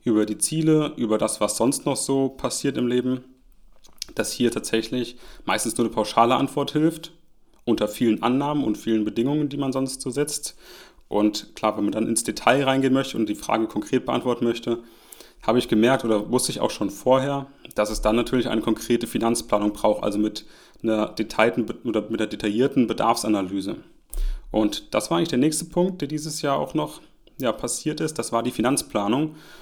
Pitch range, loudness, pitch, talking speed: 110-135 Hz, -23 LUFS, 120 Hz, 185 wpm